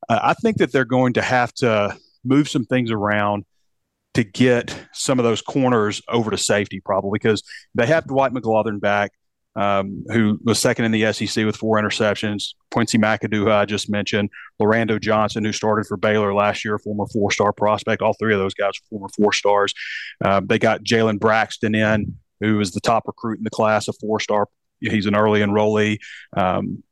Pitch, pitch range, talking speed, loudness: 105 Hz, 105-110 Hz, 185 wpm, -20 LUFS